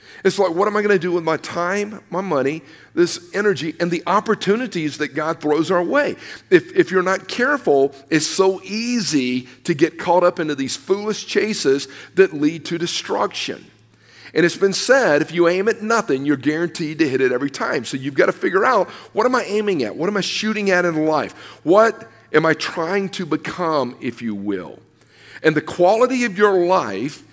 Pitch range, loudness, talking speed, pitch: 155-205 Hz, -19 LUFS, 200 wpm, 175 Hz